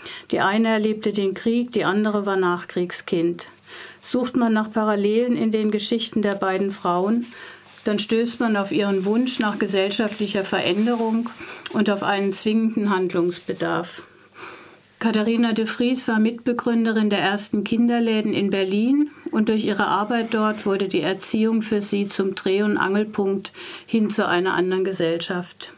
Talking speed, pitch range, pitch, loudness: 145 wpm, 195-225 Hz, 215 Hz, -22 LUFS